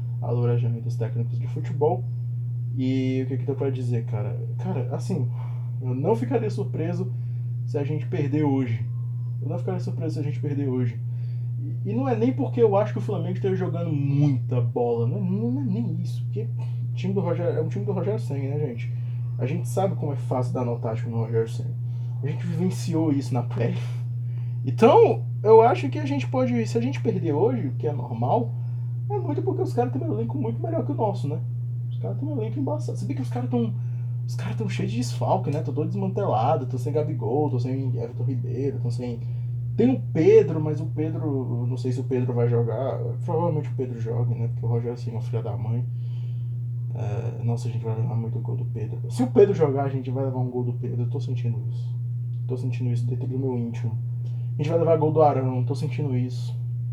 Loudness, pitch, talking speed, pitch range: -25 LUFS, 120 Hz, 225 wpm, 120-125 Hz